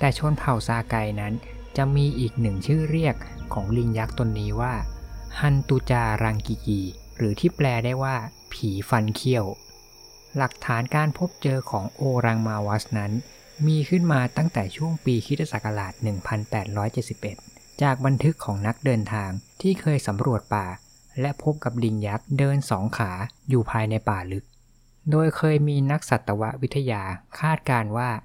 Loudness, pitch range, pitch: -25 LUFS, 110-140 Hz, 120 Hz